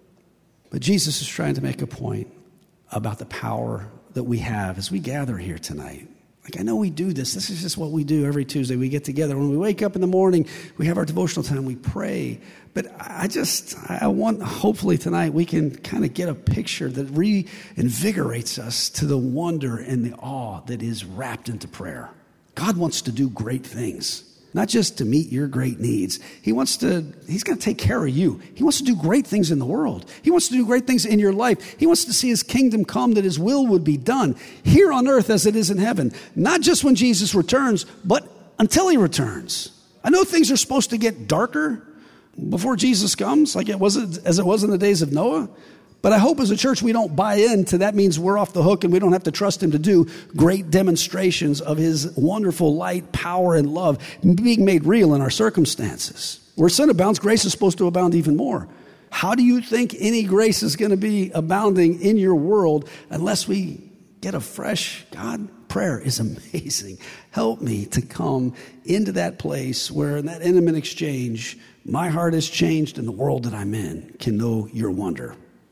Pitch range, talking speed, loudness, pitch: 135-205 Hz, 215 wpm, -21 LUFS, 175 Hz